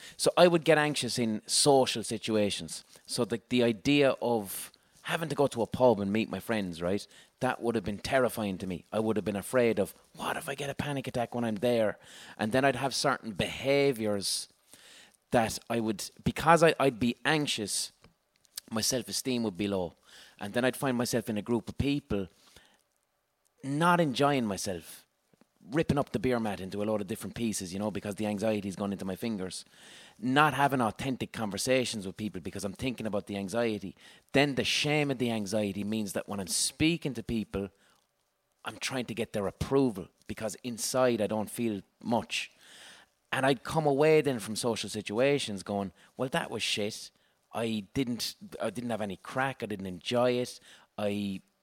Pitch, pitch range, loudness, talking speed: 115 Hz, 105-135 Hz, -30 LUFS, 190 wpm